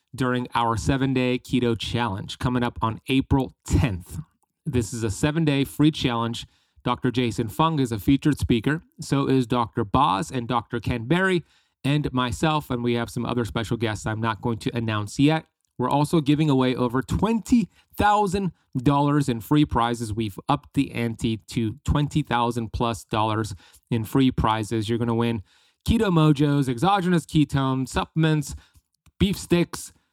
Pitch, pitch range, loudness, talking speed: 125 Hz, 115-145 Hz, -24 LUFS, 155 wpm